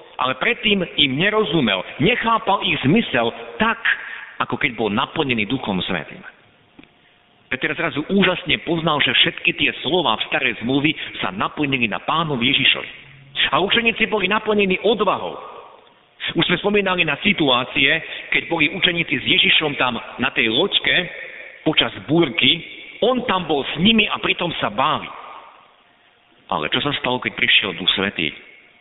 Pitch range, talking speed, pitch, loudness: 140-195 Hz, 140 wpm, 165 Hz, -18 LUFS